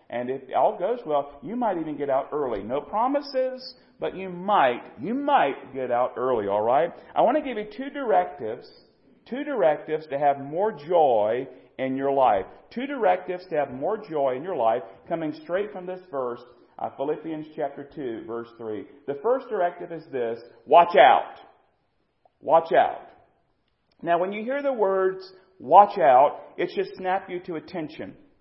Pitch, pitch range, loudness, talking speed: 175 Hz, 140-220 Hz, -24 LUFS, 170 wpm